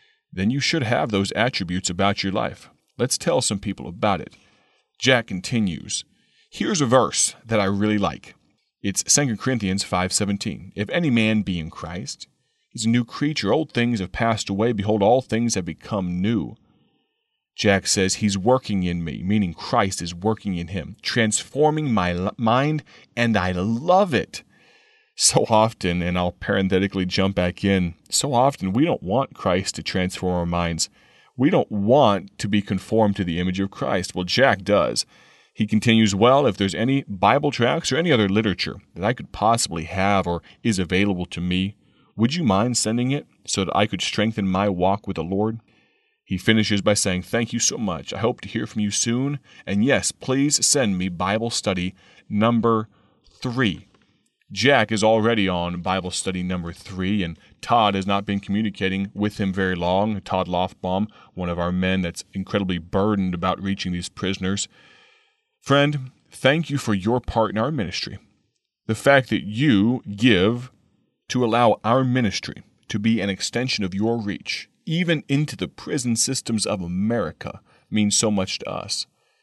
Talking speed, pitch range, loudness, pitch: 175 wpm, 95-115 Hz, -22 LUFS, 105 Hz